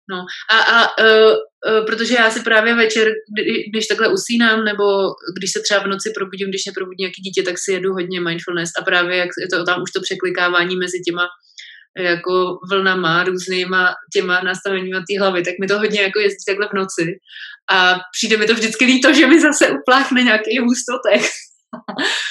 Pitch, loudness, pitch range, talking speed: 195 Hz, -16 LUFS, 180-220 Hz, 190 wpm